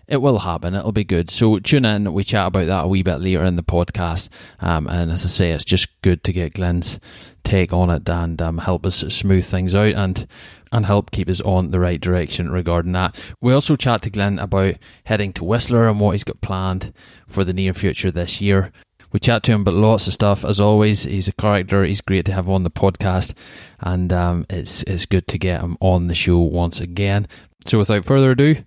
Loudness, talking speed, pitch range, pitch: -19 LUFS, 230 wpm, 90-105 Hz, 95 Hz